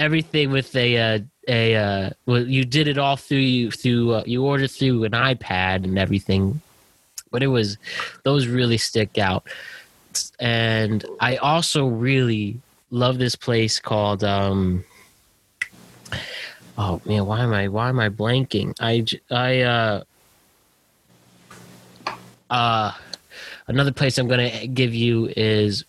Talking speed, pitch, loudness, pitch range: 135 wpm, 115 Hz, -21 LUFS, 105-130 Hz